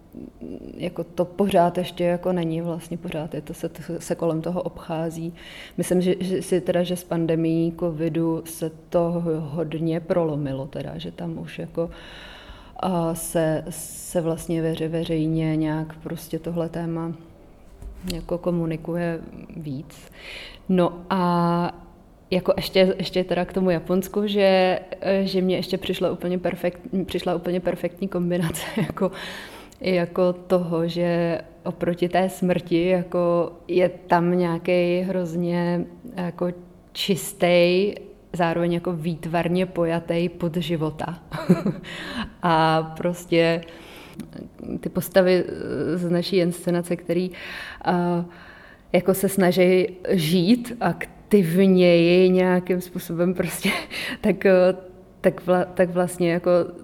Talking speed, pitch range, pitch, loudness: 115 wpm, 165-185 Hz, 175 Hz, -23 LUFS